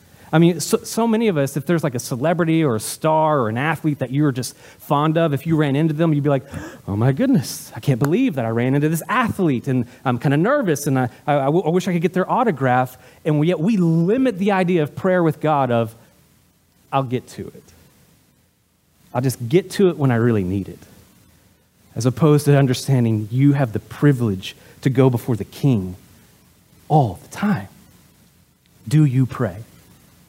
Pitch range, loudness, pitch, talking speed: 125-165 Hz, -19 LUFS, 140 Hz, 200 wpm